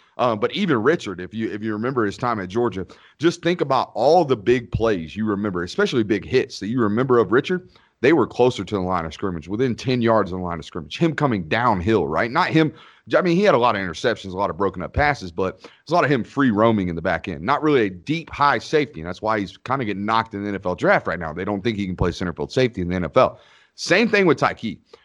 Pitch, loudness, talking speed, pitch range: 110 Hz, -21 LUFS, 275 wpm, 95-130 Hz